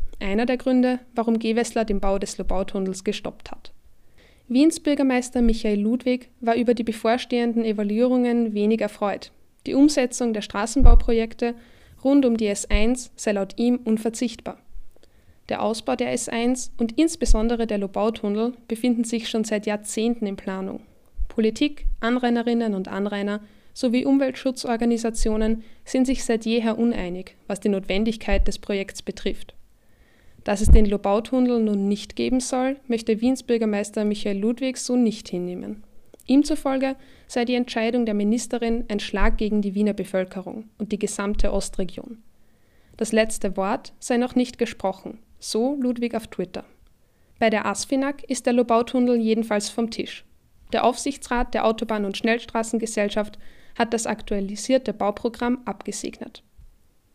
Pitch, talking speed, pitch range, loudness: 230 Hz, 135 wpm, 210-245 Hz, -24 LUFS